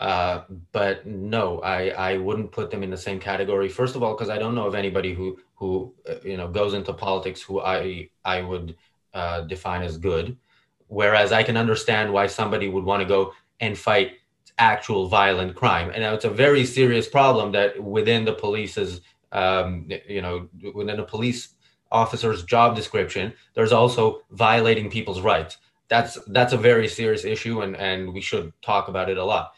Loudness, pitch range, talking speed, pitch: -23 LUFS, 95-110 Hz, 185 wpm, 100 Hz